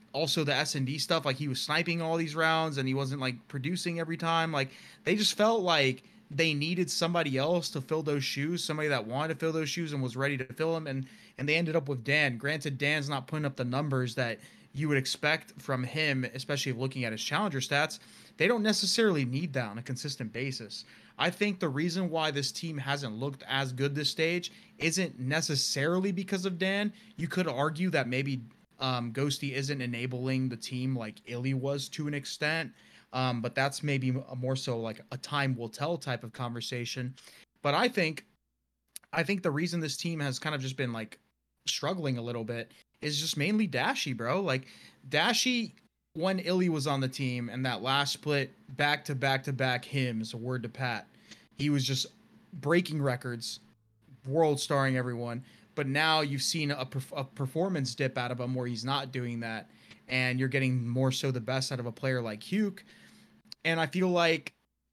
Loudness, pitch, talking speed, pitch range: -31 LUFS, 140 Hz, 200 wpm, 130-160 Hz